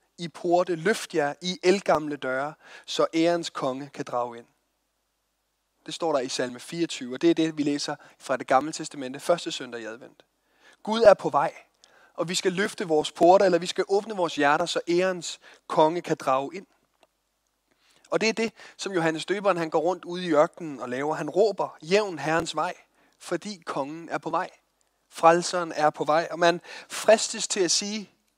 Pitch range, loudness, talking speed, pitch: 150-180 Hz, -25 LUFS, 190 wpm, 165 Hz